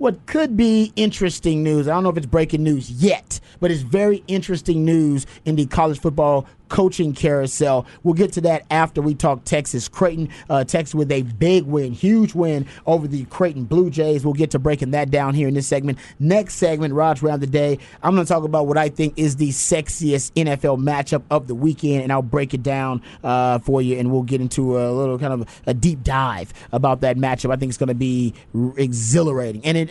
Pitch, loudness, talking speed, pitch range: 150 Hz, -19 LUFS, 225 wpm, 135-165 Hz